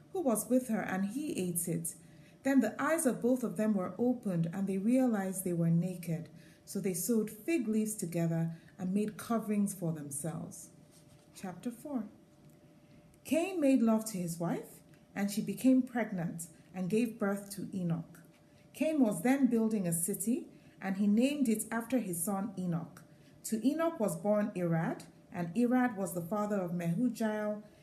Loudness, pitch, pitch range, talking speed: -33 LUFS, 200 Hz, 175-235 Hz, 165 wpm